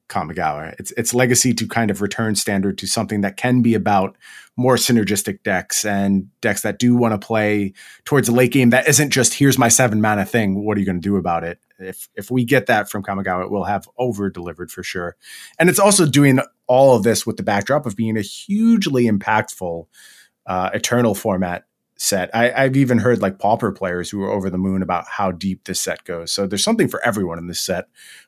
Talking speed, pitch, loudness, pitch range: 220 wpm, 105 Hz, -18 LUFS, 95-125 Hz